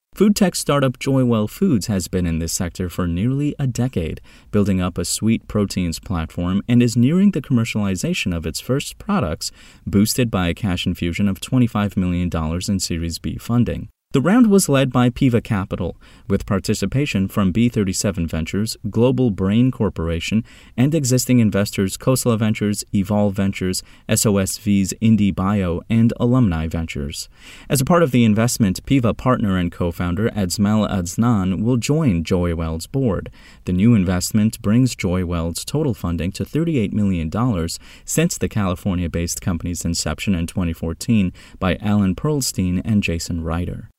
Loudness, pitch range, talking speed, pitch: -19 LUFS, 90-120 Hz, 150 wpm, 100 Hz